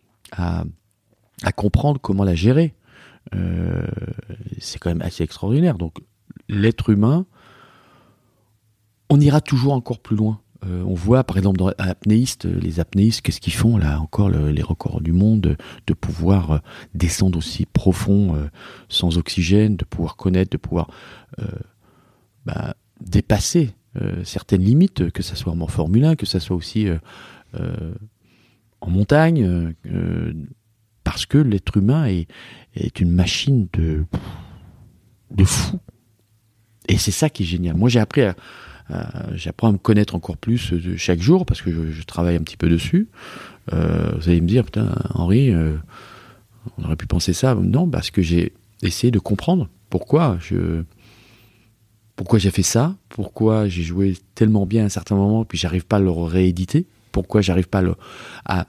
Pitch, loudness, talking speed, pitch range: 105 Hz, -20 LUFS, 170 wpm, 90-115 Hz